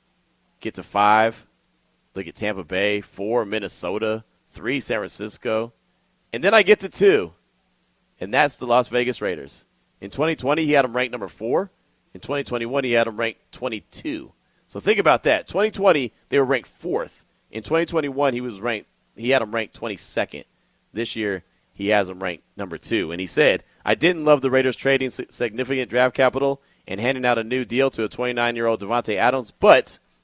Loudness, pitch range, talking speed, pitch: -22 LUFS, 110-135 Hz, 180 wpm, 120 Hz